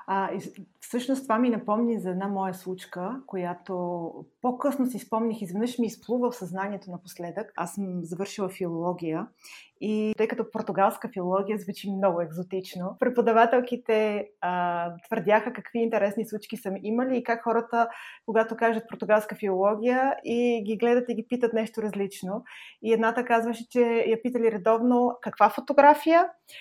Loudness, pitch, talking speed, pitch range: -27 LUFS, 220 Hz, 140 wpm, 195-235 Hz